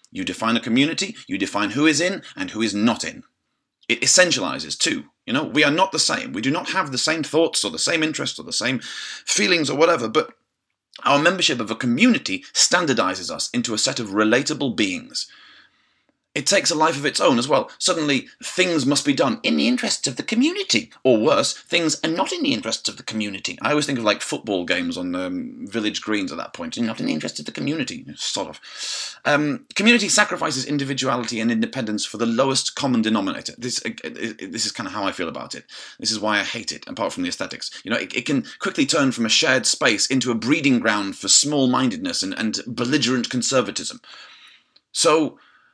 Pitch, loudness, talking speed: 160 Hz, -21 LUFS, 215 wpm